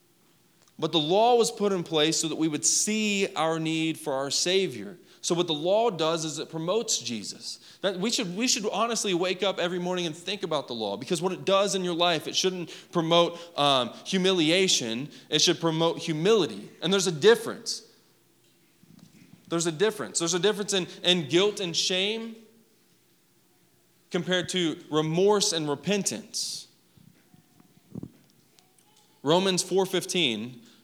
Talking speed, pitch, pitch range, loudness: 155 wpm, 175 Hz, 160-195 Hz, -26 LUFS